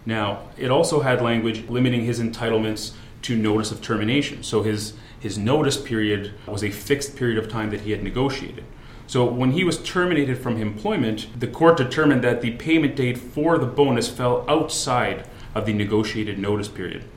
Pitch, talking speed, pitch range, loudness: 115 Hz, 180 wpm, 110-130 Hz, -22 LUFS